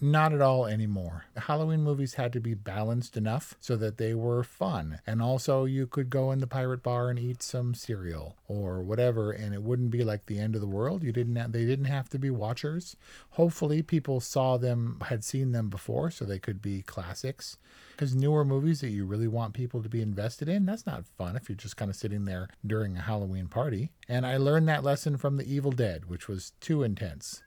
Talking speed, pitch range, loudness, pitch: 225 wpm, 105-135 Hz, -31 LUFS, 120 Hz